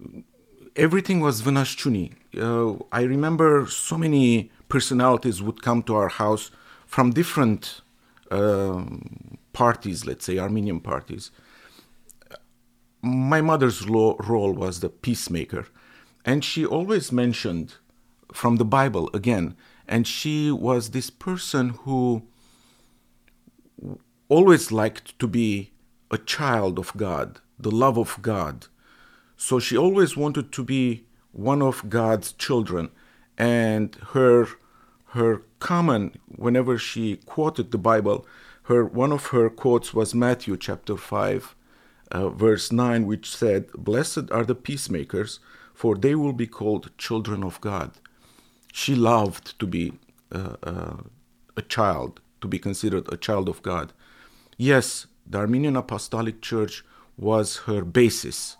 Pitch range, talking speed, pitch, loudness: 105-130 Hz, 125 wpm, 115 Hz, -23 LUFS